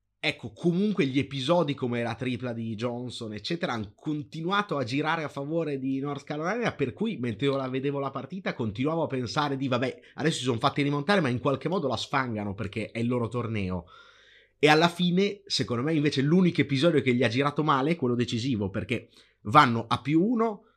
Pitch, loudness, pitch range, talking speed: 140 Hz, -27 LUFS, 120-160 Hz, 195 wpm